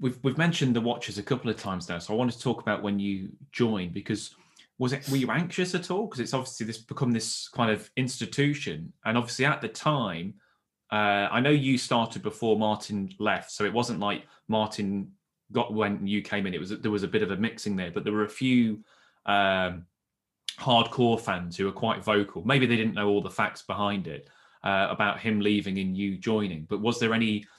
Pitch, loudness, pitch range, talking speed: 110 Hz, -28 LUFS, 100-125 Hz, 220 wpm